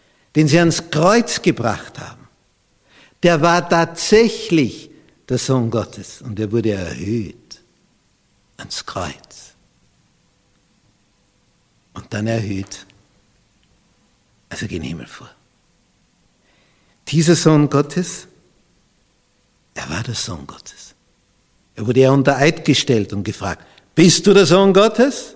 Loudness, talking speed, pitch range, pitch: -16 LUFS, 110 wpm, 110-170 Hz, 140 Hz